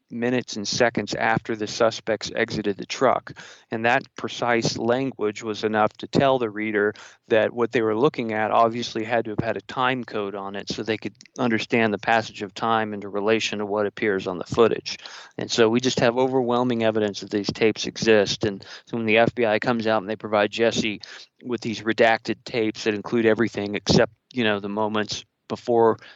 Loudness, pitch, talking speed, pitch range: -23 LUFS, 110 Hz, 195 wpm, 105-115 Hz